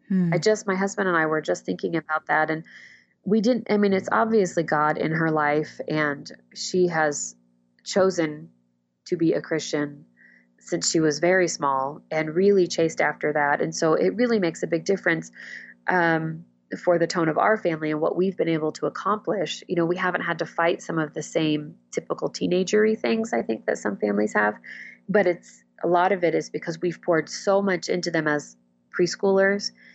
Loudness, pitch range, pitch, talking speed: -24 LUFS, 145-180 Hz, 165 Hz, 195 wpm